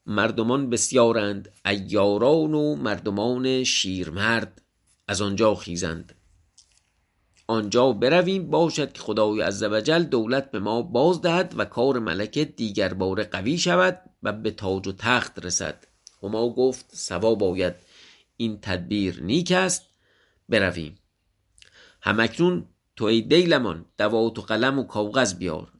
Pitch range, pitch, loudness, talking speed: 95-130 Hz, 110 Hz, -23 LUFS, 125 wpm